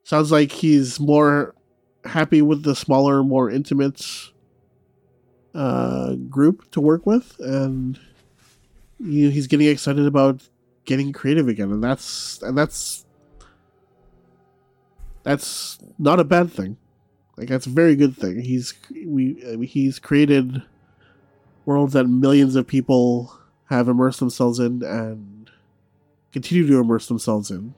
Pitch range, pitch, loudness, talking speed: 120-145 Hz, 135 Hz, -19 LUFS, 130 wpm